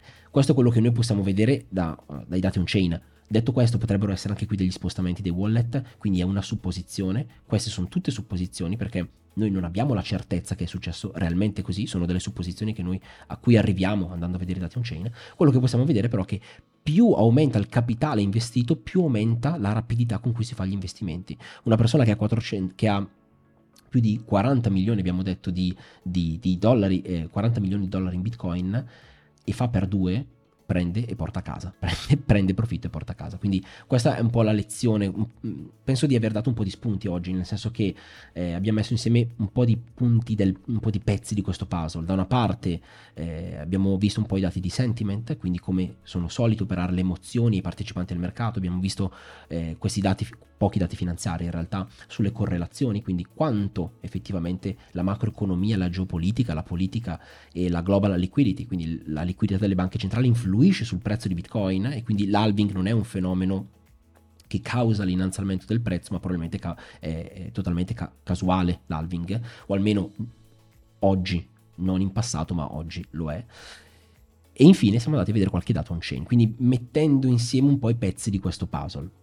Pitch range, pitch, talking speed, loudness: 90-115 Hz, 100 Hz, 200 wpm, -25 LUFS